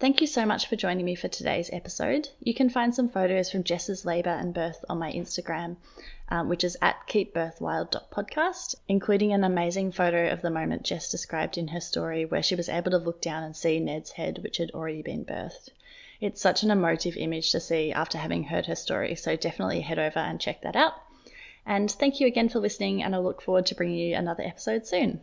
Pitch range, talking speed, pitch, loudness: 170-210 Hz, 220 wpm, 180 Hz, -28 LUFS